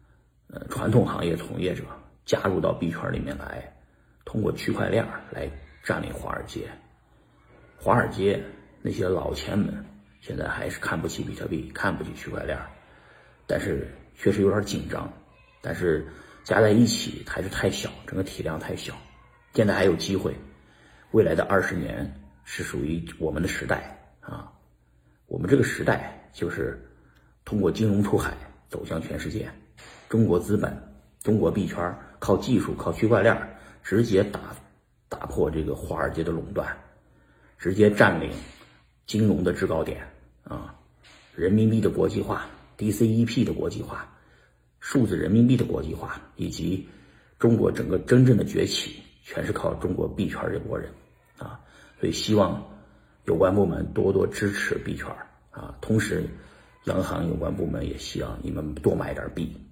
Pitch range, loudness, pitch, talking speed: 65-105 Hz, -26 LUFS, 80 Hz, 235 characters per minute